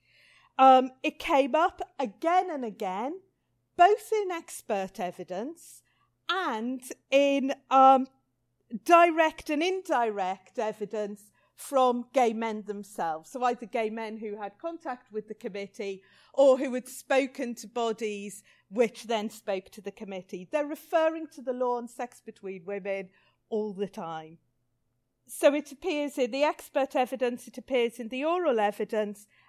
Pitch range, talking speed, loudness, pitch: 210-280 Hz, 140 wpm, -28 LUFS, 245 Hz